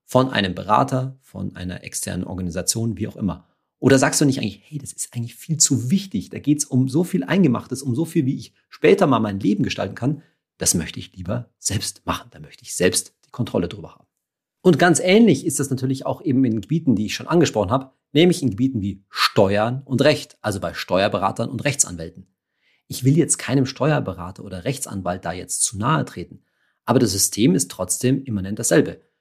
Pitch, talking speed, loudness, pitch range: 125 Hz, 205 wpm, -20 LUFS, 100-145 Hz